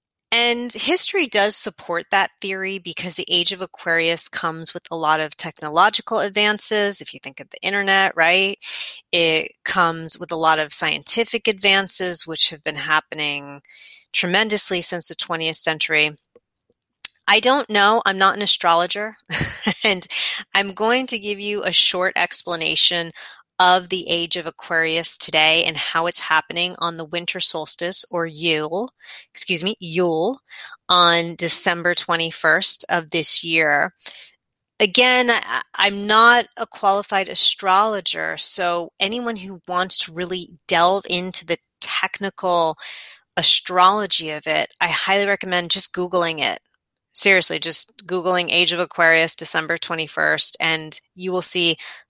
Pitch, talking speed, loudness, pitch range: 180 Hz, 140 wpm, -17 LUFS, 165-200 Hz